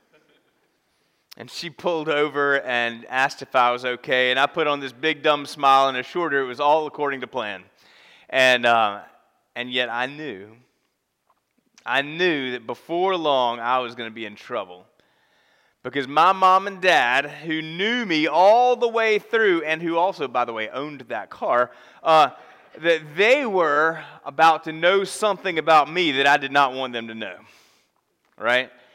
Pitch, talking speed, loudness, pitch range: 145 Hz, 175 wpm, -21 LUFS, 125-165 Hz